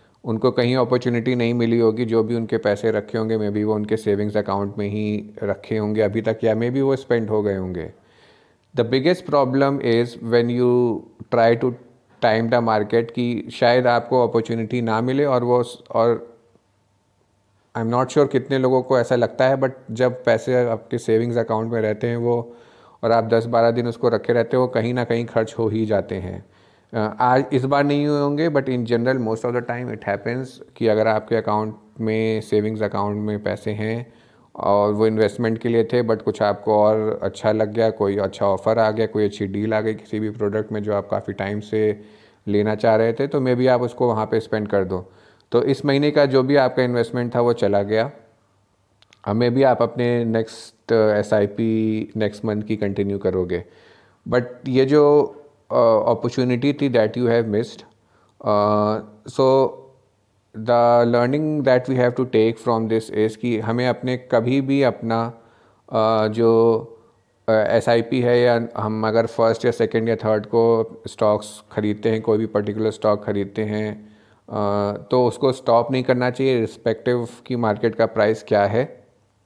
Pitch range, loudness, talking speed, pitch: 105-125 Hz, -20 LUFS, 185 wpm, 115 Hz